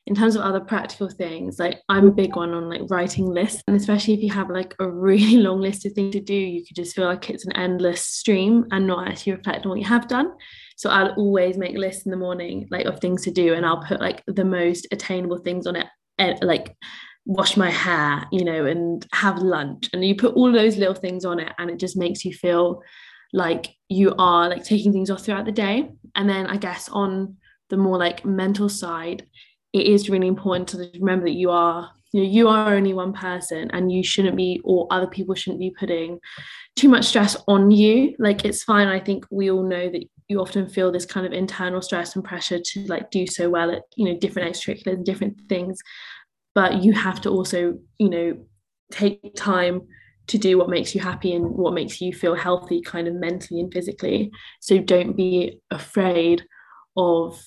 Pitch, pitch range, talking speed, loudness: 185 Hz, 180-200 Hz, 220 wpm, -21 LUFS